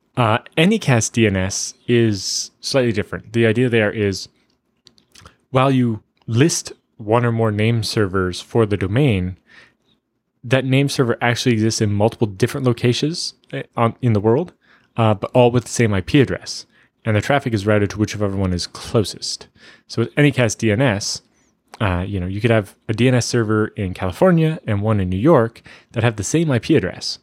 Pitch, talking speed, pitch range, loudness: 115 Hz, 170 wpm, 105-125 Hz, -18 LUFS